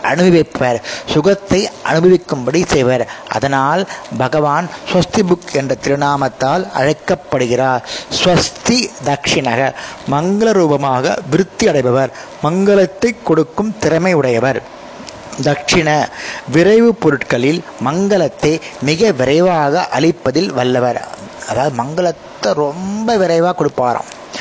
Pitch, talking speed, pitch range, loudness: 155 Hz, 85 wpm, 135-180 Hz, -14 LUFS